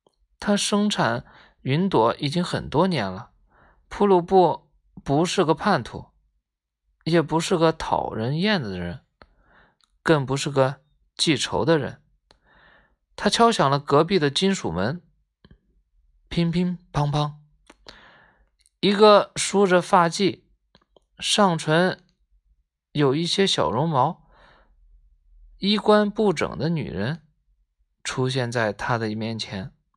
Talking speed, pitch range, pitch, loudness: 155 characters per minute, 110-185 Hz, 150 Hz, -22 LUFS